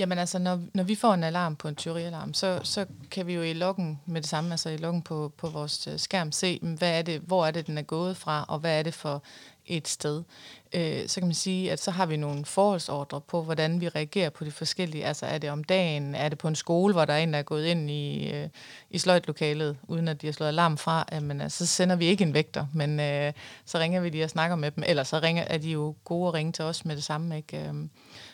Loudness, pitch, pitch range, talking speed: -28 LUFS, 160 Hz, 150-175 Hz, 260 wpm